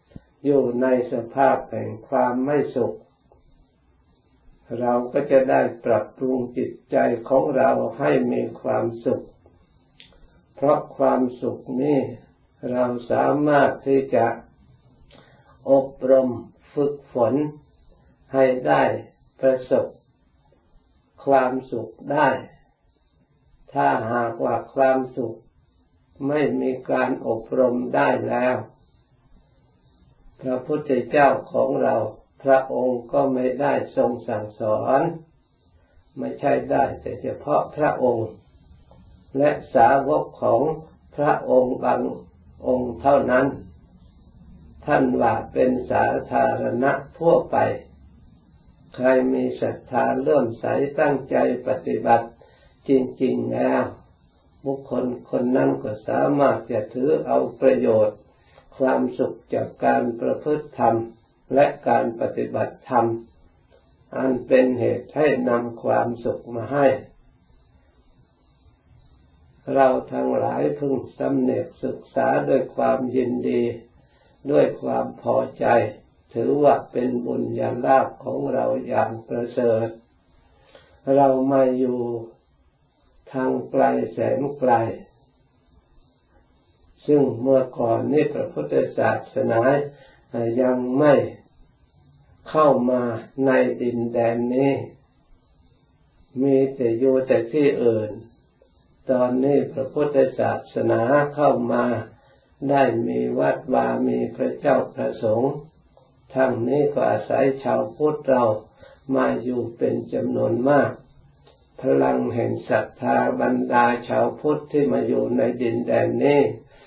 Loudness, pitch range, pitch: -22 LUFS, 110-135 Hz, 125 Hz